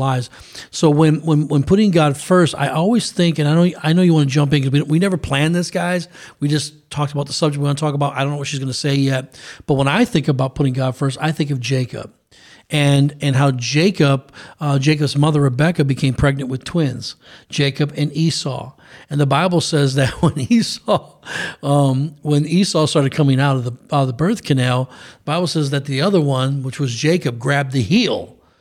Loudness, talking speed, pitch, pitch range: -17 LUFS, 225 wpm, 145 Hz, 135-160 Hz